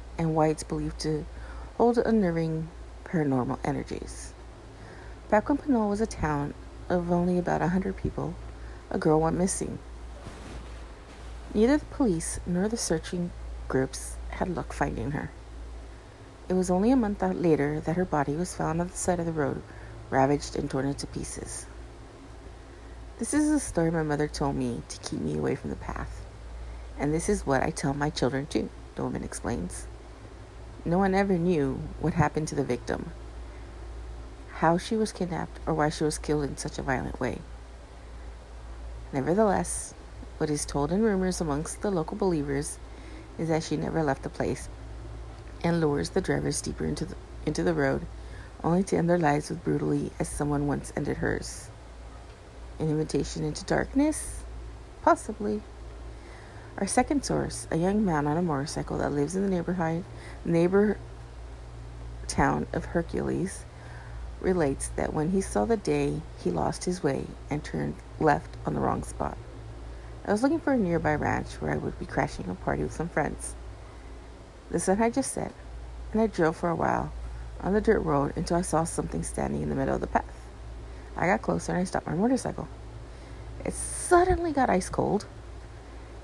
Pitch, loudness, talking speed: 150 Hz, -28 LUFS, 170 wpm